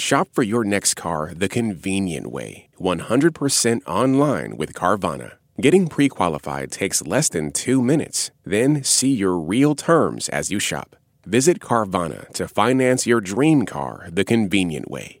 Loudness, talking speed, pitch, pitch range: -20 LUFS, 150 wpm, 115 Hz, 90-130 Hz